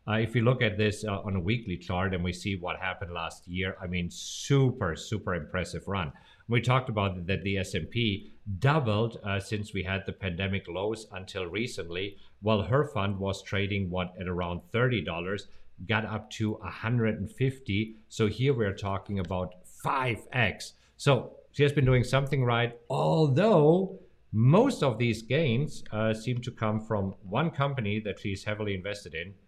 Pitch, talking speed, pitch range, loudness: 105 Hz, 170 wpm, 95-120 Hz, -29 LUFS